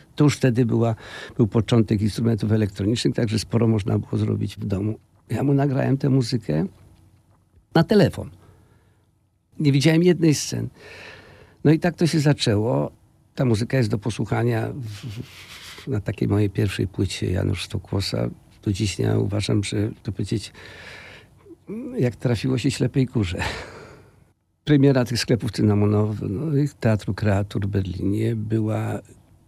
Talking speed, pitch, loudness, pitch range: 140 wpm, 110 Hz, -22 LUFS, 105-125 Hz